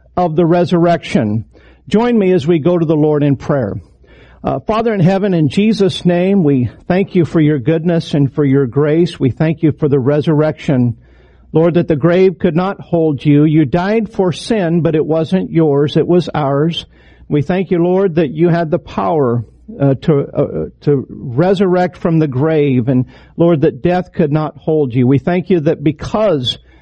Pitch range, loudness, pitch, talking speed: 140-175 Hz, -14 LUFS, 160 Hz, 190 wpm